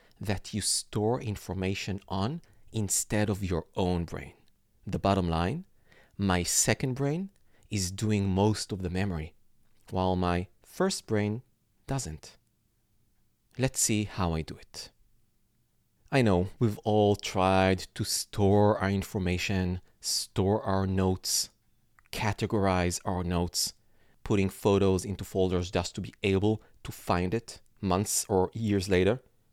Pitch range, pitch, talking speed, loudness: 95-110 Hz, 100 Hz, 130 wpm, -29 LUFS